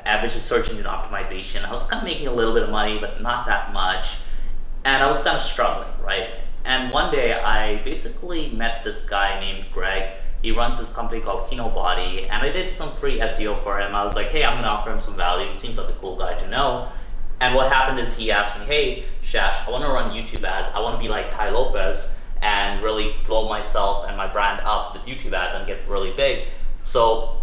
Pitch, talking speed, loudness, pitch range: 105 Hz, 230 wpm, -23 LUFS, 100-115 Hz